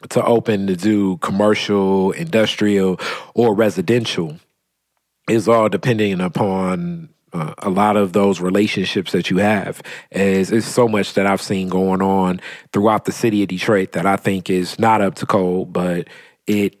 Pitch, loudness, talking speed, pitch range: 100 Hz, -17 LUFS, 160 wpm, 95-110 Hz